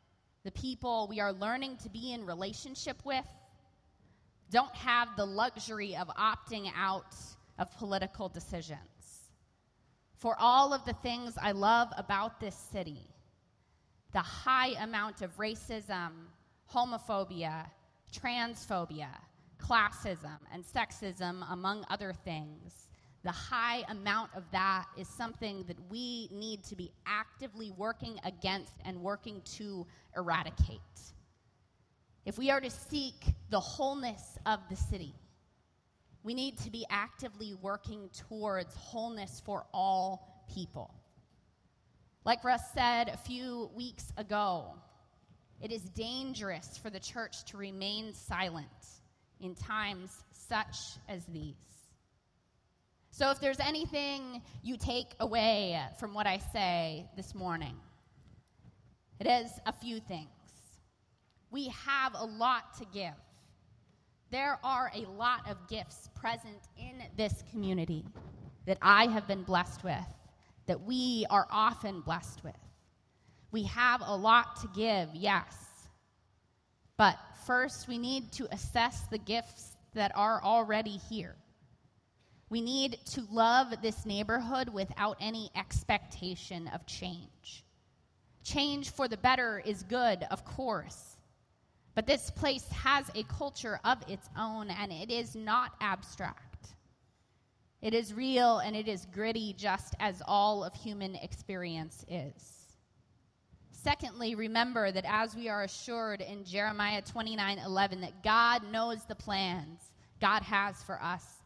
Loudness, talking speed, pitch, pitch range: -34 LUFS, 125 wpm, 210 Hz, 185-235 Hz